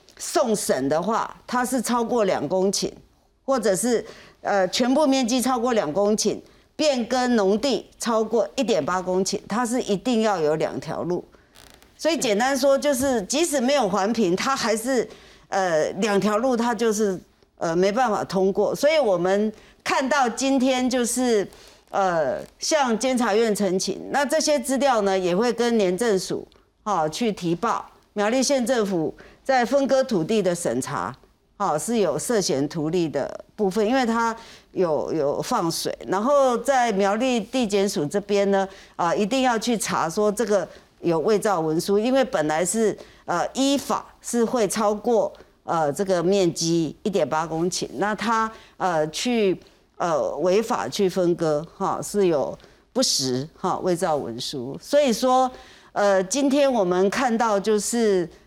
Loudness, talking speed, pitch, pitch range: -23 LUFS, 225 characters per minute, 210 Hz, 190-250 Hz